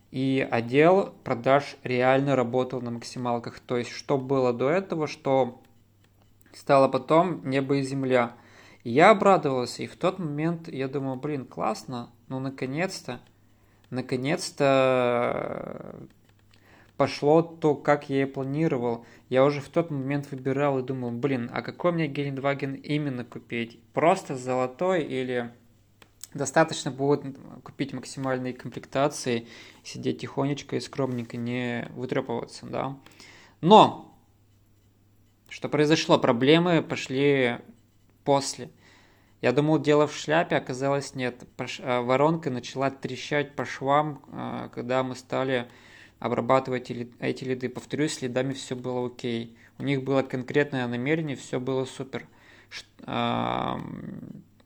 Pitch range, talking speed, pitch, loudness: 120-140 Hz, 115 wpm, 130 Hz, -26 LUFS